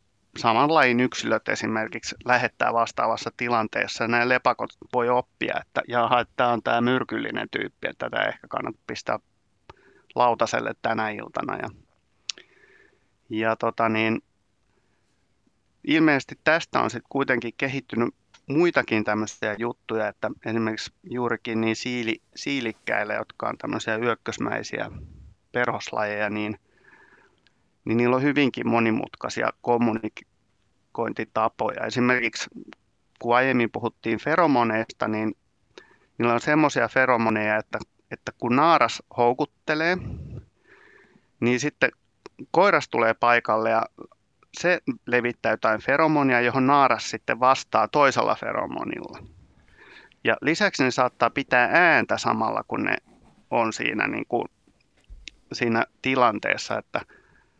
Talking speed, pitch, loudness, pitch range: 105 wpm, 120 Hz, -24 LUFS, 110-125 Hz